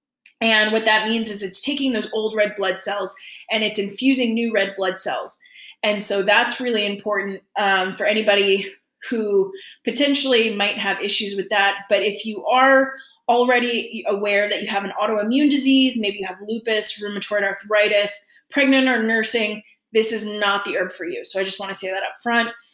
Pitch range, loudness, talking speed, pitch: 200-235 Hz, -19 LUFS, 185 wpm, 215 Hz